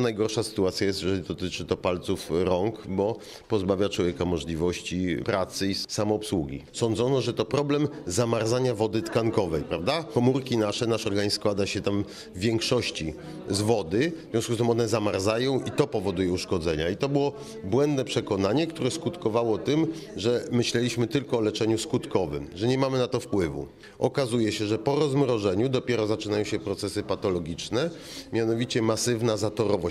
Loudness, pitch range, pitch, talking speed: -27 LUFS, 100-125 Hz, 110 Hz, 155 wpm